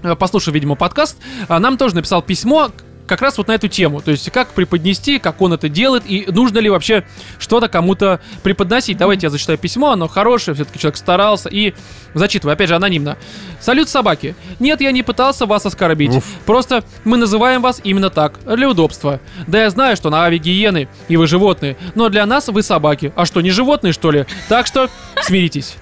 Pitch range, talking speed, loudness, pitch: 165-235 Hz, 190 wpm, -14 LUFS, 195 Hz